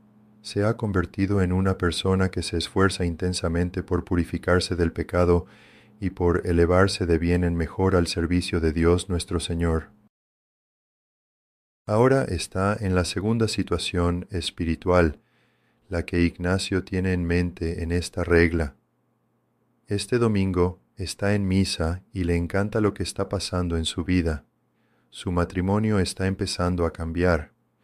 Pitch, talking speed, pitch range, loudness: 90 Hz, 140 wpm, 85-100 Hz, -24 LUFS